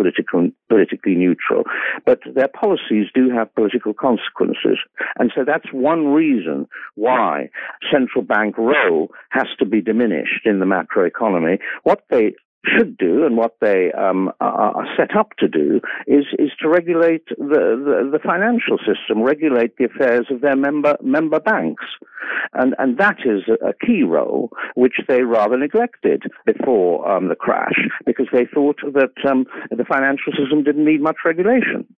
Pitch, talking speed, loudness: 150 Hz, 155 wpm, -17 LUFS